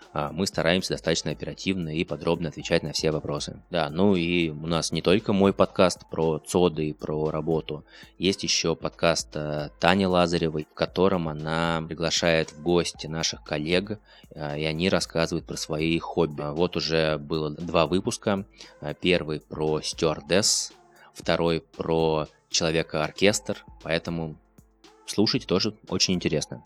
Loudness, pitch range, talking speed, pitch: -25 LUFS, 80-90 Hz, 135 wpm, 80 Hz